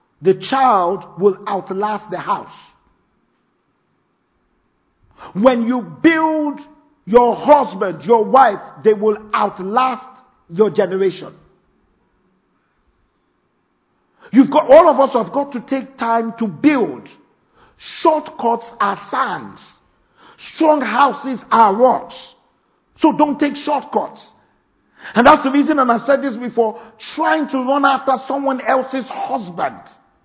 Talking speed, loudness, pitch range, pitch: 115 wpm, -16 LUFS, 220-285 Hz, 255 Hz